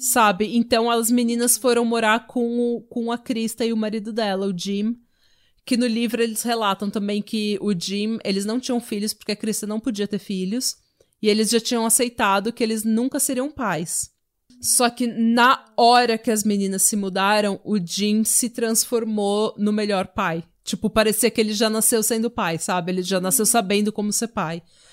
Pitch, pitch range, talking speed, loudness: 220 Hz, 205-235 Hz, 190 wpm, -21 LUFS